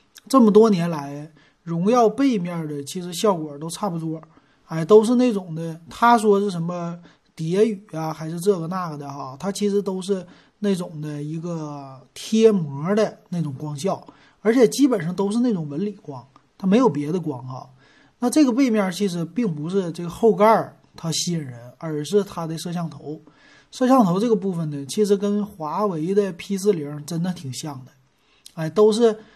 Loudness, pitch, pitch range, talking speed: -21 LUFS, 175 Hz, 155-210 Hz, 260 characters per minute